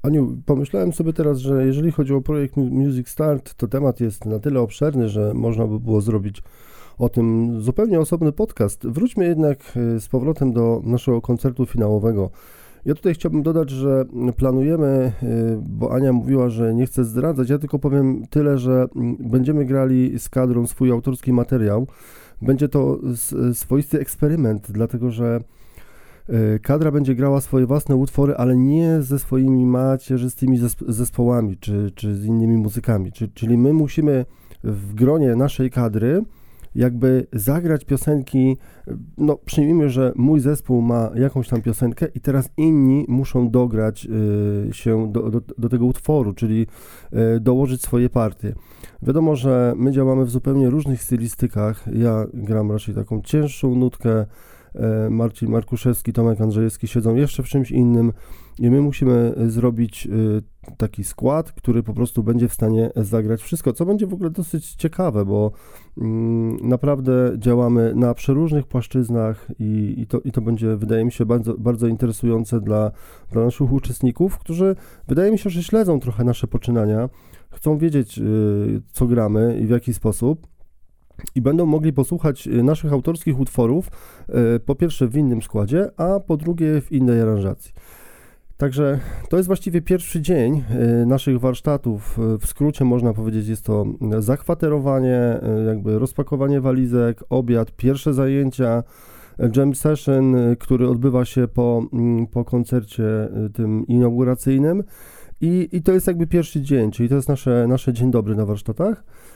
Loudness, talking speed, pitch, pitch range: -19 LUFS, 145 wpm, 125 Hz, 115-140 Hz